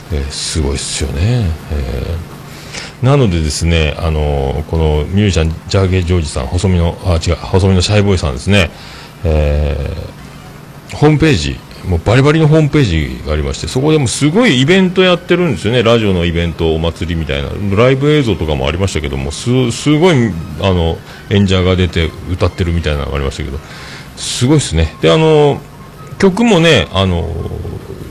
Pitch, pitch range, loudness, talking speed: 95 Hz, 80-130 Hz, -13 LUFS, 395 characters per minute